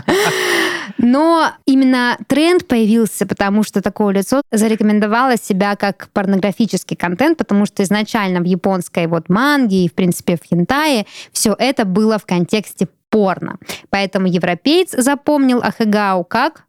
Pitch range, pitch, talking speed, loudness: 195-250 Hz, 210 Hz, 130 wpm, -15 LUFS